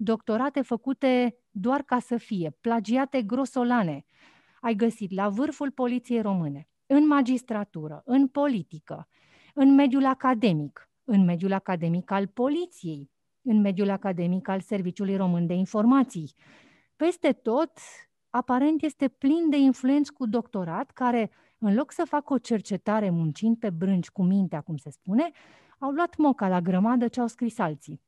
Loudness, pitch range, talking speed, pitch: -26 LUFS, 185-270 Hz, 145 wpm, 230 Hz